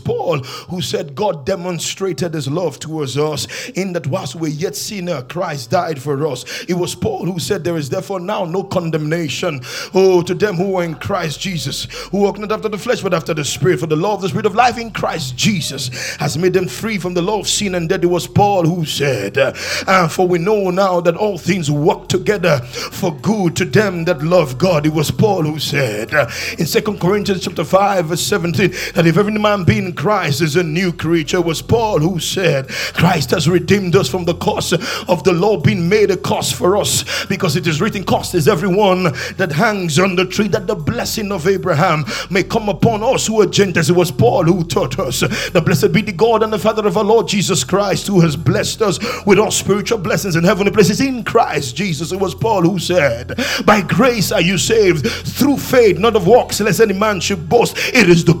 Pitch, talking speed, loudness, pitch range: 180 Hz, 220 wpm, -16 LUFS, 165-200 Hz